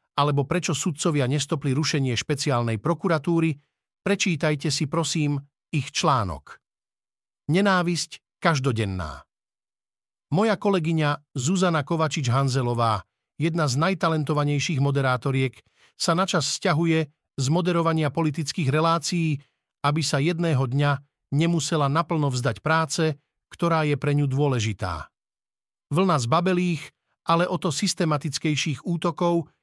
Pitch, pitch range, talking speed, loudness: 155 Hz, 140-170 Hz, 100 wpm, -24 LUFS